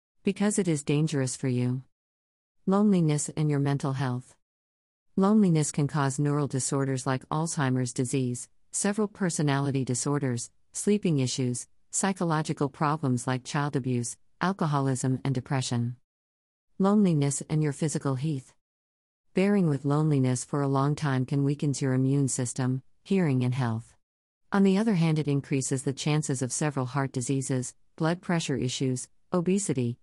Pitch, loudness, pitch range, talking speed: 140 Hz, -28 LUFS, 125-155 Hz, 135 wpm